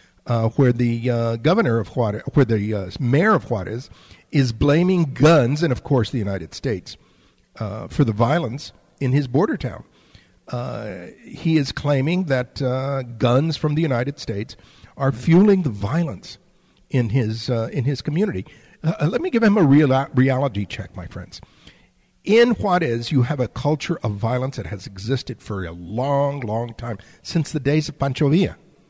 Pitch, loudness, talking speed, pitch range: 135 Hz, -21 LUFS, 175 wpm, 115-150 Hz